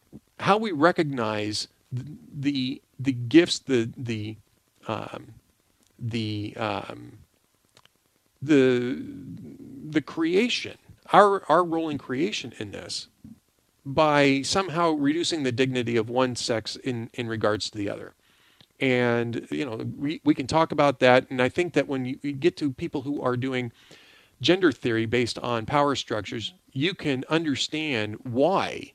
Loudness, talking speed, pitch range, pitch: -25 LUFS, 140 wpm, 120-150 Hz, 130 Hz